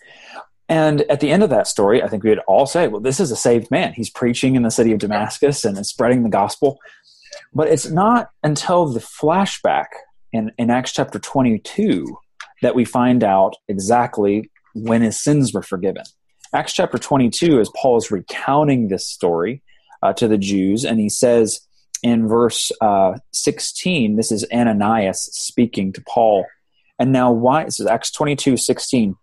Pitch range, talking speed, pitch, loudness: 110-145 Hz, 175 wpm, 120 Hz, -17 LUFS